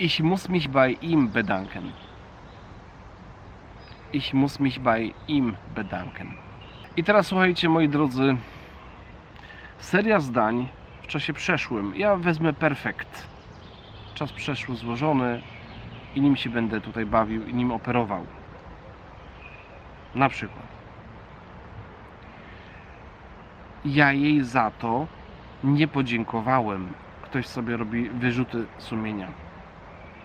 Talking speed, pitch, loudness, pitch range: 100 wpm, 125 Hz, -25 LUFS, 110-145 Hz